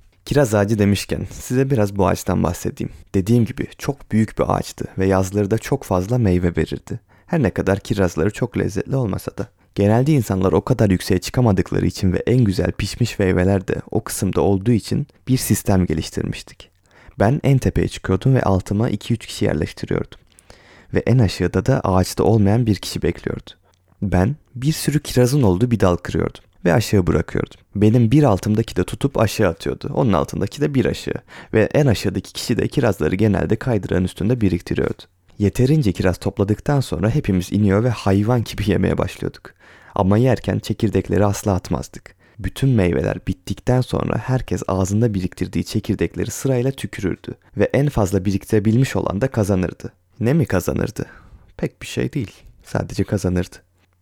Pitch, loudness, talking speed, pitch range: 100 Hz, -19 LUFS, 160 wpm, 95-120 Hz